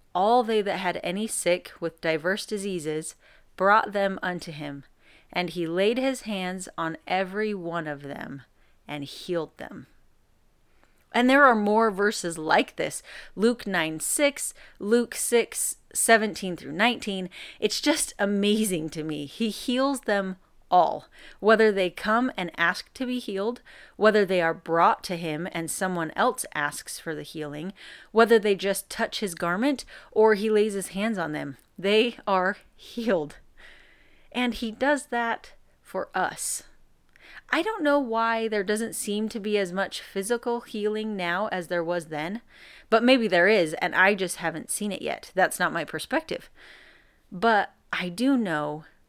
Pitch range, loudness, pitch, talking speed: 170-230 Hz, -25 LUFS, 200 Hz, 160 wpm